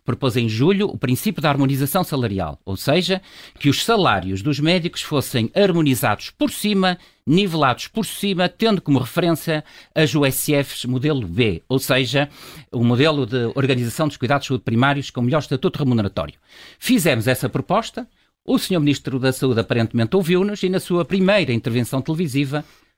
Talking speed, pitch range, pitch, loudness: 155 wpm, 125-180 Hz, 145 Hz, -20 LUFS